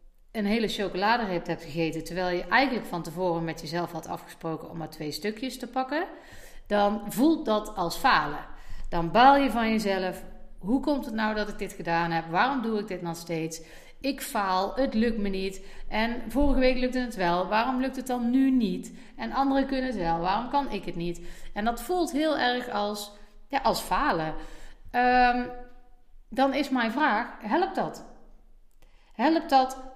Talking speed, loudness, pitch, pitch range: 180 wpm, -27 LUFS, 215 Hz, 180-260 Hz